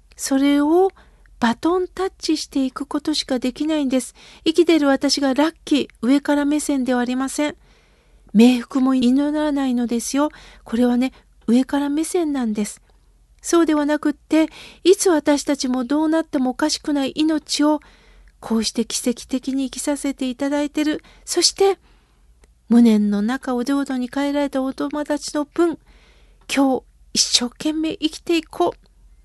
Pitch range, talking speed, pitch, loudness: 255-305 Hz, 310 characters per minute, 285 Hz, -20 LUFS